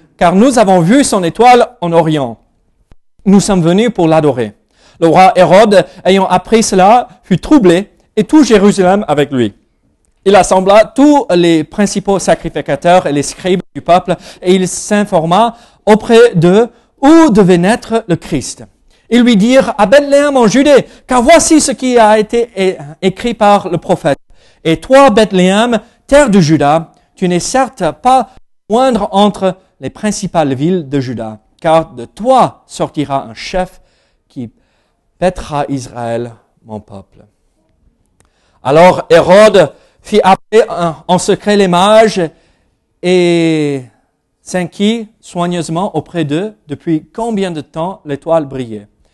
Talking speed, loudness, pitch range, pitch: 135 wpm, -10 LUFS, 160-220 Hz, 185 Hz